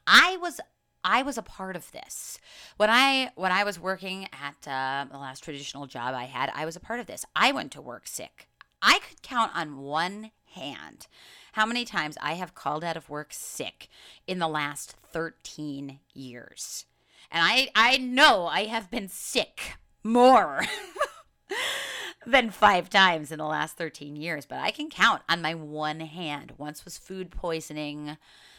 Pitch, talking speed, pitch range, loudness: 170 Hz, 175 wpm, 150-225 Hz, -26 LUFS